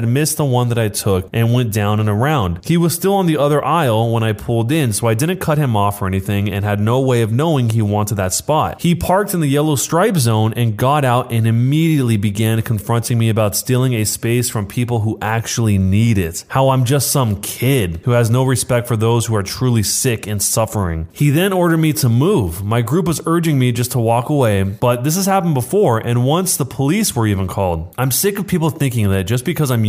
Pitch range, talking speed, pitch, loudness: 110-145 Hz, 235 wpm, 120 Hz, -16 LUFS